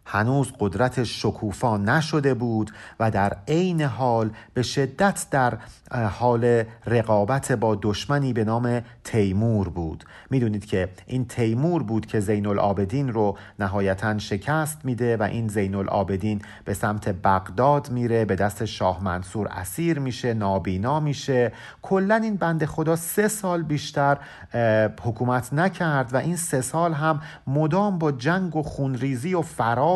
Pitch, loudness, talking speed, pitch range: 120 Hz, -24 LUFS, 140 wpm, 105-145 Hz